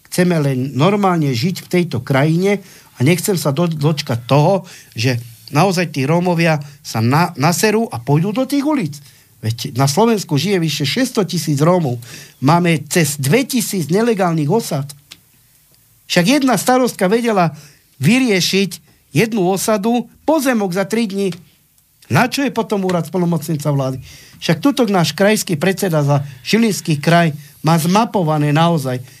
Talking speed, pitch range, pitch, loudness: 140 wpm, 145-200 Hz, 170 Hz, -16 LUFS